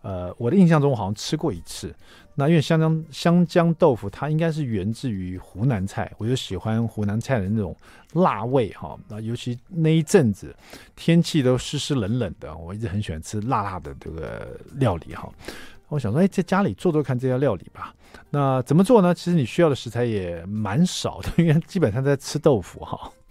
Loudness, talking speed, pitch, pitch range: -22 LUFS, 310 characters per minute, 130 Hz, 105-160 Hz